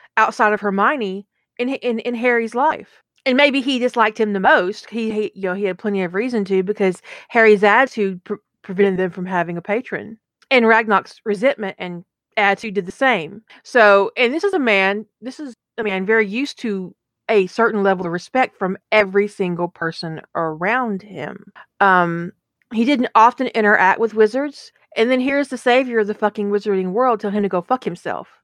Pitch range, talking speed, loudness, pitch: 195-235 Hz, 190 wpm, -18 LUFS, 210 Hz